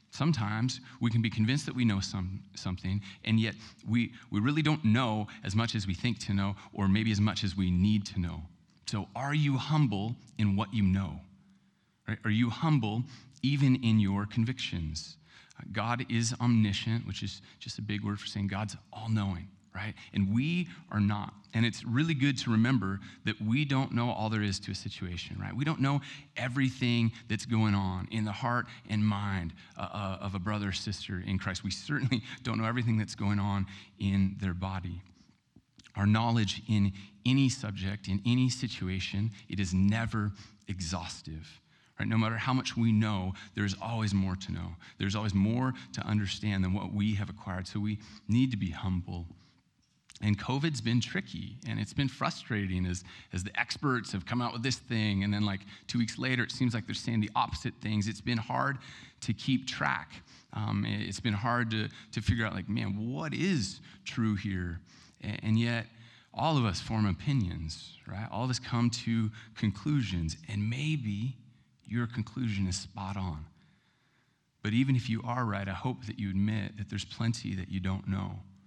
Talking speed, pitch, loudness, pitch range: 190 wpm, 110 Hz, -32 LUFS, 100-120 Hz